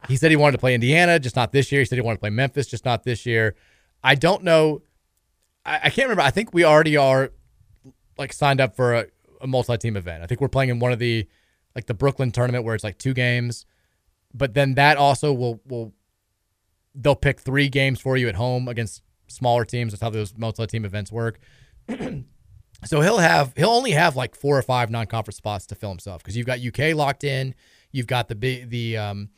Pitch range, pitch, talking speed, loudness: 110-135 Hz, 125 Hz, 225 wpm, -21 LUFS